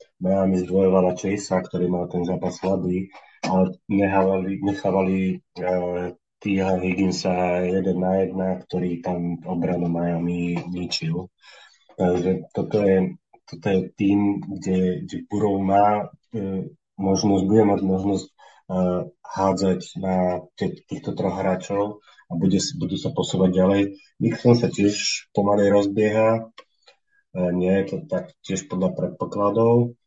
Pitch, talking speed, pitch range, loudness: 95 Hz, 130 wpm, 90-100 Hz, -23 LUFS